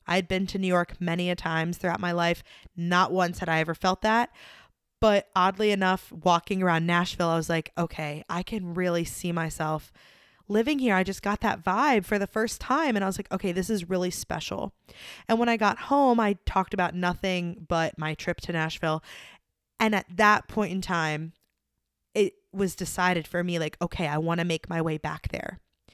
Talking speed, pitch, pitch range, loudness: 200 wpm, 180 Hz, 170-205 Hz, -27 LUFS